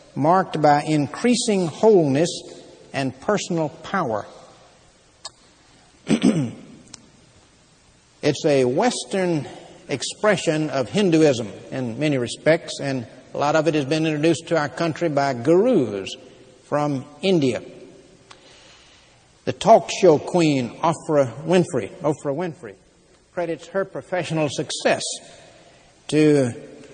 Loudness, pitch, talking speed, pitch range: -21 LUFS, 155 Hz, 100 wpm, 140-175 Hz